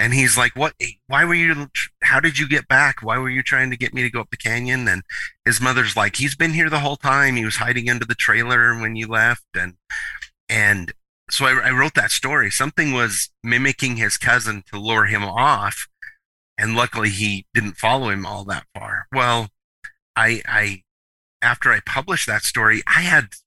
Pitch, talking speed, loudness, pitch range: 120 Hz, 200 wpm, -18 LUFS, 110-130 Hz